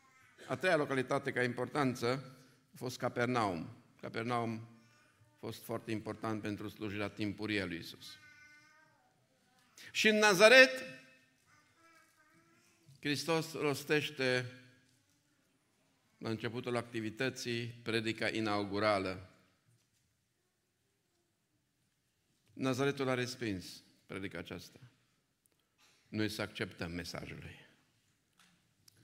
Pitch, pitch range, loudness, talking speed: 125 Hz, 110-140 Hz, -34 LUFS, 80 wpm